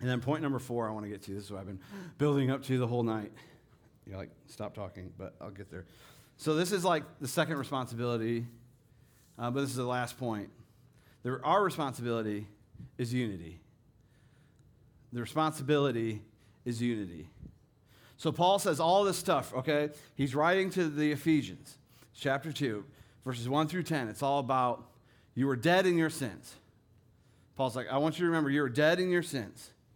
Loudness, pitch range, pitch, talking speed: -32 LUFS, 115-150 Hz, 130 Hz, 185 wpm